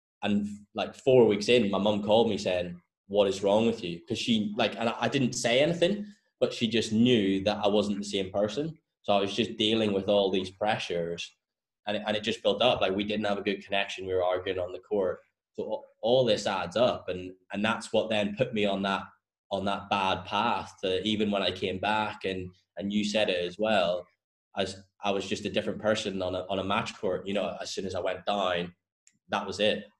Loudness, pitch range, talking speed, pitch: -28 LUFS, 95-110 Hz, 235 wpm, 100 Hz